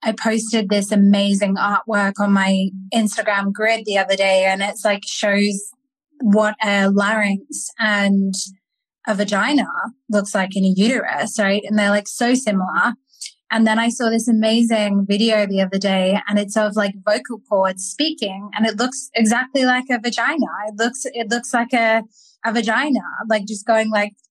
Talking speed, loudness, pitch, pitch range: 170 wpm, -18 LUFS, 215 Hz, 200-230 Hz